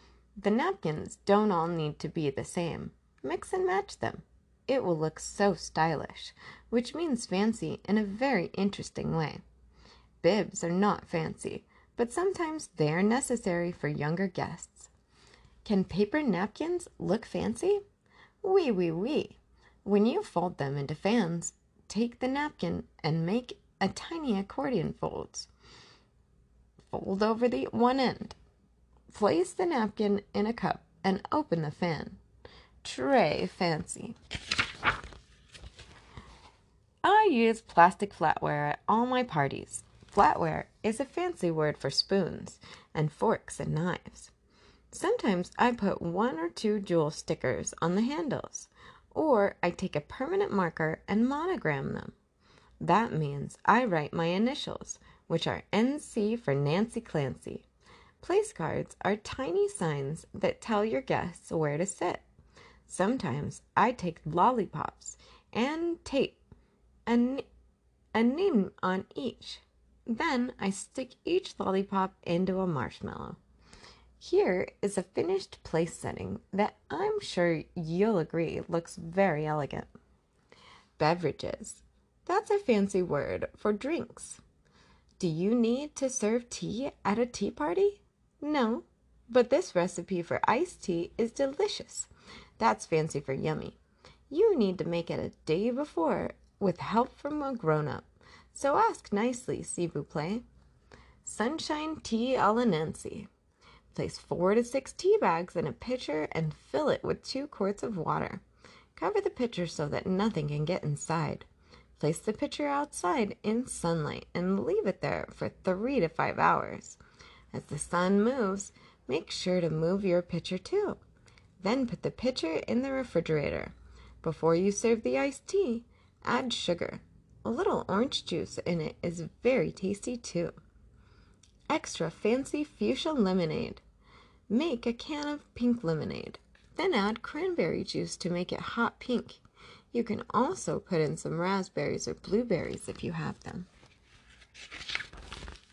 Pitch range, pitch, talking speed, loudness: 170-255 Hz, 205 Hz, 140 wpm, -31 LUFS